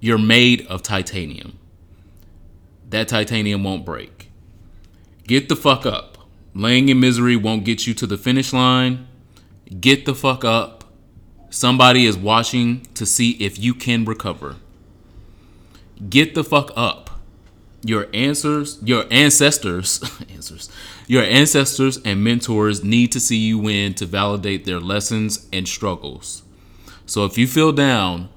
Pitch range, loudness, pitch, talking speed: 95-125 Hz, -17 LUFS, 105 Hz, 135 wpm